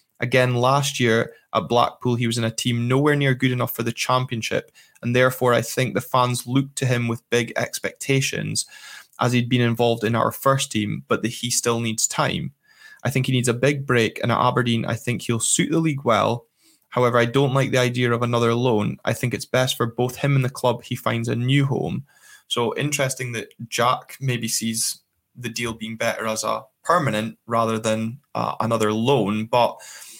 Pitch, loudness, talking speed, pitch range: 120 Hz, -22 LUFS, 205 wpm, 115-130 Hz